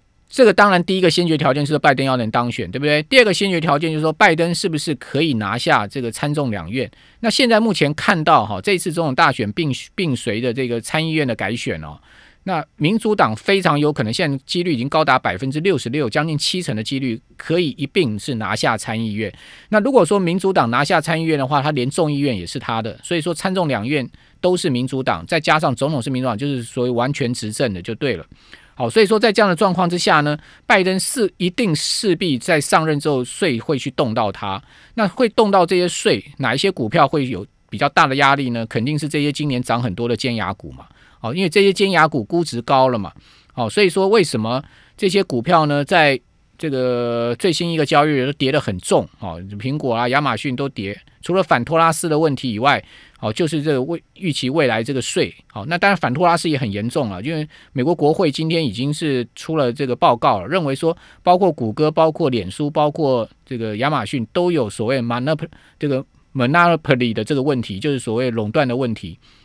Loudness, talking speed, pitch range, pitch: -18 LUFS, 345 characters per minute, 125-170 Hz, 145 Hz